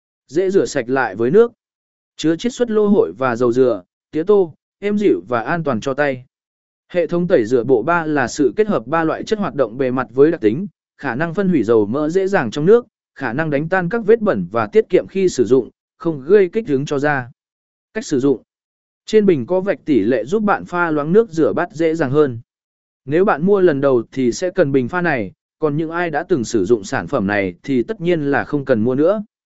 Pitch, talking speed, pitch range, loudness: 175 Hz, 245 wpm, 145-210 Hz, -17 LUFS